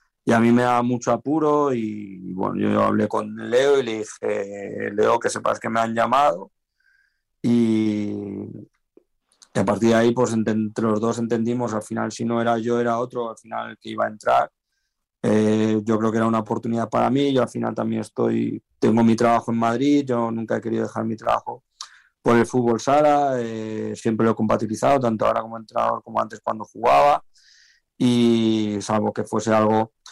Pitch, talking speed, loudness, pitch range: 115 Hz, 190 wpm, -21 LUFS, 110-120 Hz